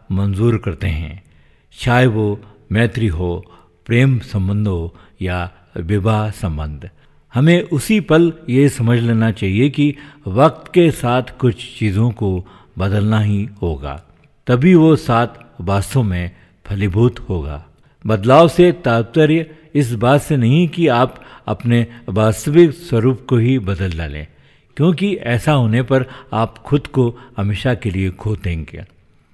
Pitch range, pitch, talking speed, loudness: 95-130 Hz, 115 Hz, 135 wpm, -16 LUFS